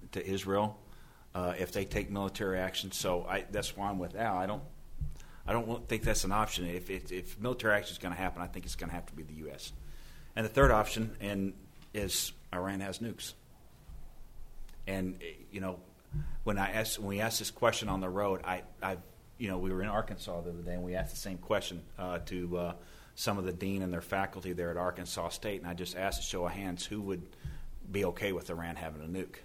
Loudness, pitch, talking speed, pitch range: -36 LUFS, 95 Hz, 230 wpm, 90-105 Hz